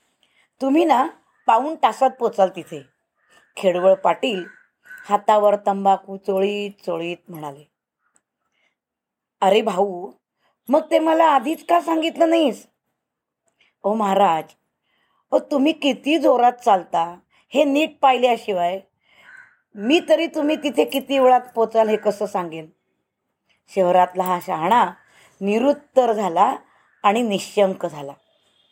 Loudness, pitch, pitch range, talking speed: -19 LUFS, 215 Hz, 190-290 Hz, 105 wpm